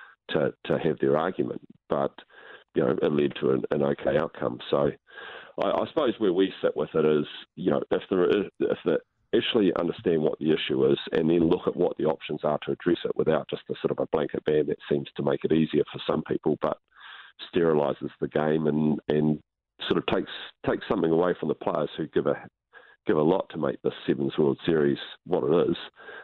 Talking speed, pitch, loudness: 215 wpm, 75 Hz, -27 LUFS